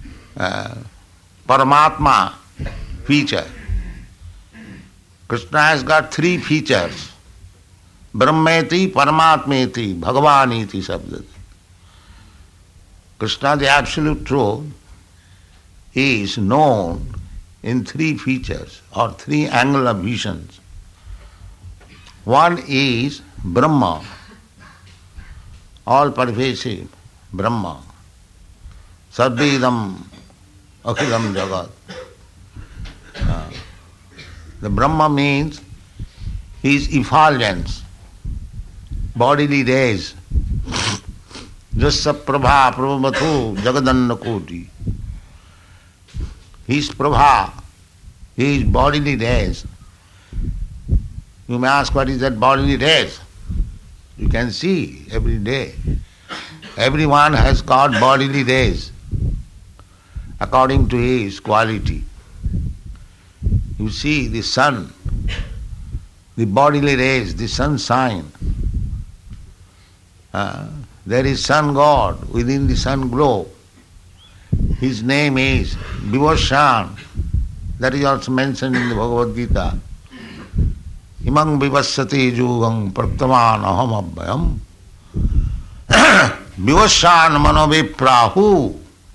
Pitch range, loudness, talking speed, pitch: 90-135 Hz, -16 LUFS, 65 wpm, 105 Hz